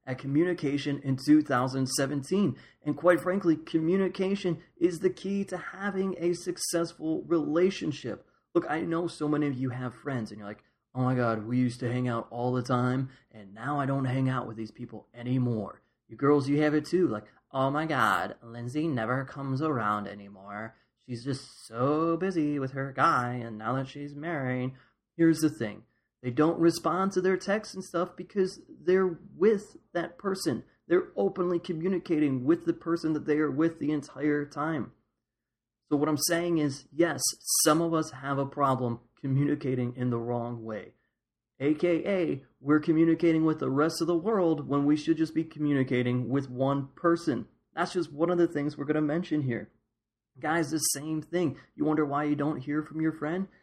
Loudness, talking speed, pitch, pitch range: -29 LUFS, 185 wpm, 150 Hz, 125-170 Hz